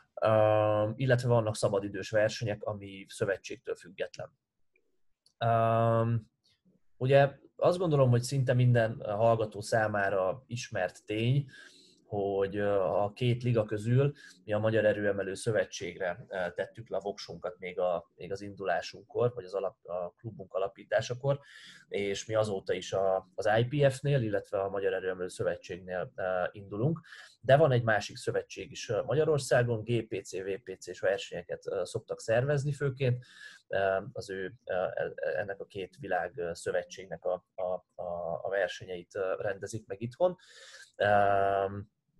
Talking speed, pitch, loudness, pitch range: 130 wpm, 115 Hz, -31 LUFS, 105-150 Hz